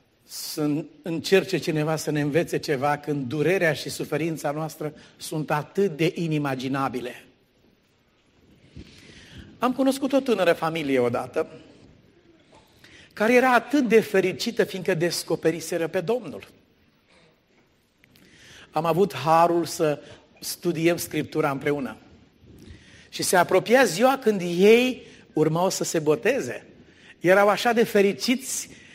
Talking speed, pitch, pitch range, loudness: 110 wpm, 165 Hz, 150-200 Hz, -23 LUFS